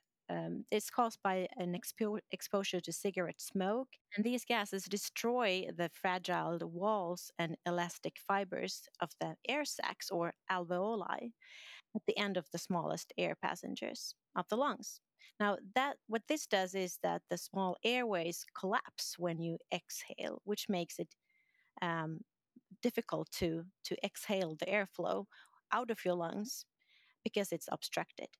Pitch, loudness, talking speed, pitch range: 195 Hz, -39 LUFS, 145 wpm, 175-225 Hz